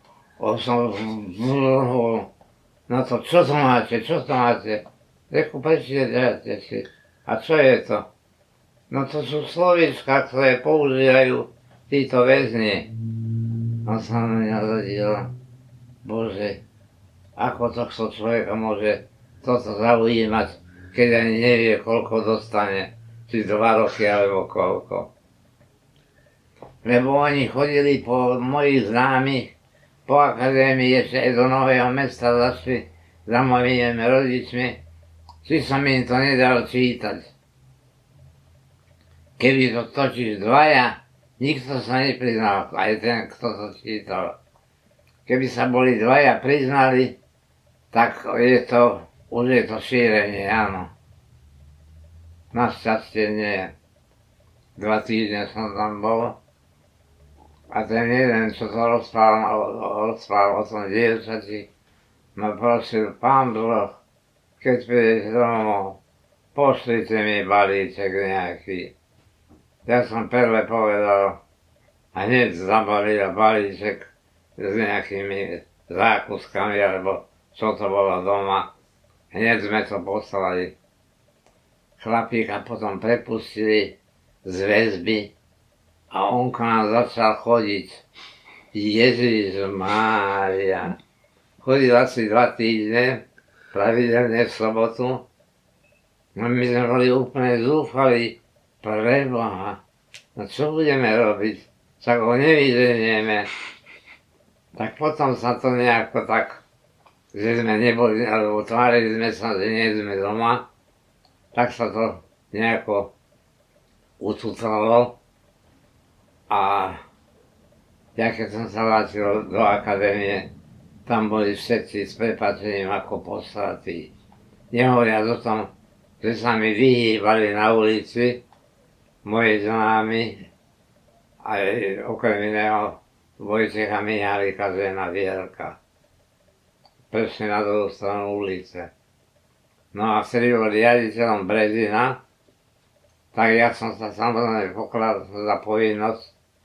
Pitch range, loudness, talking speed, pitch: 105-120 Hz, -21 LUFS, 105 wpm, 110 Hz